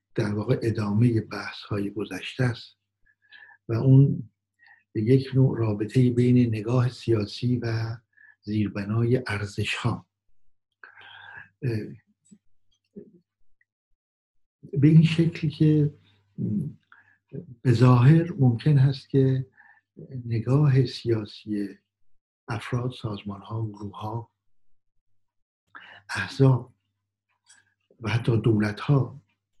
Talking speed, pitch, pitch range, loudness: 80 wpm, 115 Hz, 100-130 Hz, -24 LUFS